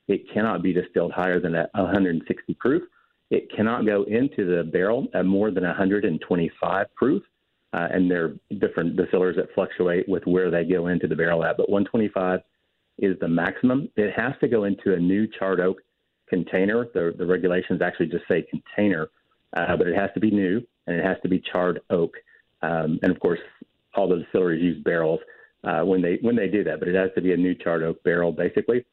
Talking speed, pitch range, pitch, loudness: 205 wpm, 85-100 Hz, 90 Hz, -24 LUFS